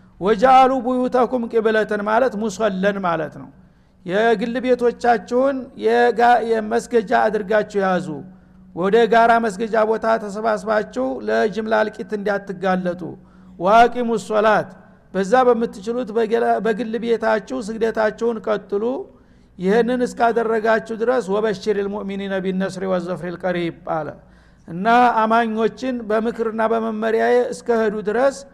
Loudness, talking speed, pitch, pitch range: -19 LUFS, 90 wpm, 225 Hz, 205-235 Hz